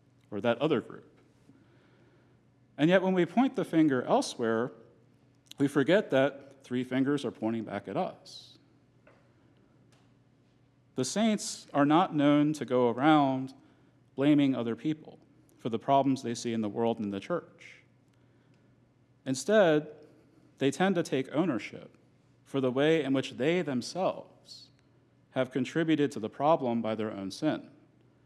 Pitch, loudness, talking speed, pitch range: 135 Hz, -29 LUFS, 140 wpm, 125-150 Hz